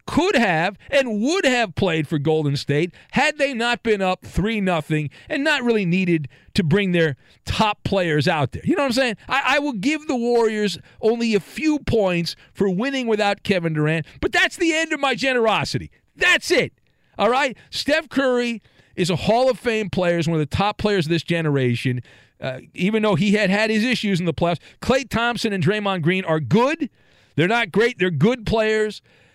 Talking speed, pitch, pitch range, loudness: 200 wpm, 205 Hz, 170-240 Hz, -20 LUFS